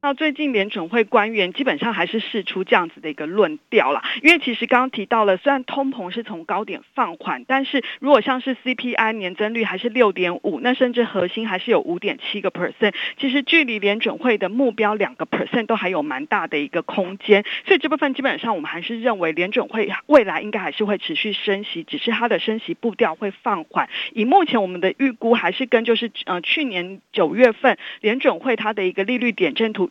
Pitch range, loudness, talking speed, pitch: 200-265 Hz, -20 LUFS, 355 characters per minute, 230 Hz